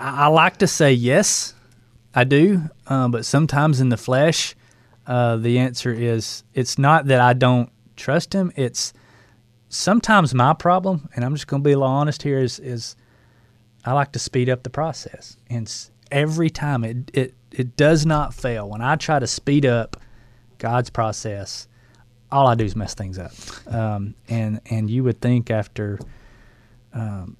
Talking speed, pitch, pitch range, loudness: 175 wpm, 125 Hz, 115-140 Hz, -20 LUFS